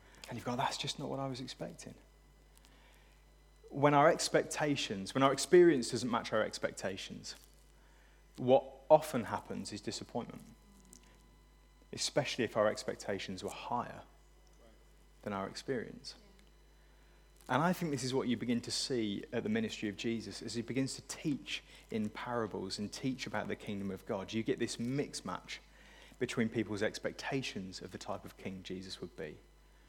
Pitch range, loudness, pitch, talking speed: 100-135 Hz, -36 LUFS, 120 Hz, 160 wpm